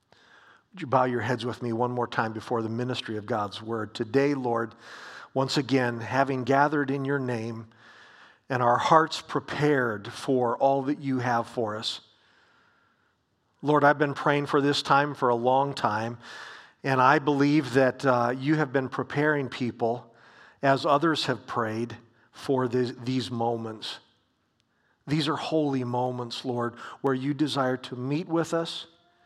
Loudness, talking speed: -26 LUFS, 155 wpm